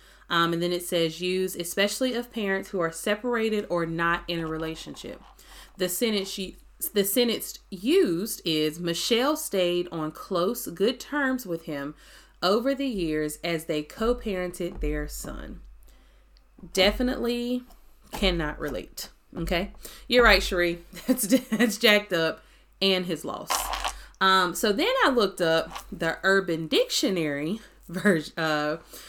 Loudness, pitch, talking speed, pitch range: -26 LUFS, 185 Hz, 135 wpm, 170-220 Hz